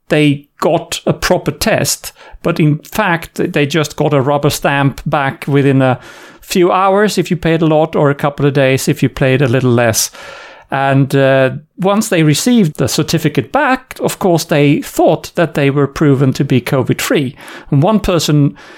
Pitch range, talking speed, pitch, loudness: 140-170 Hz, 185 wpm, 150 Hz, -13 LUFS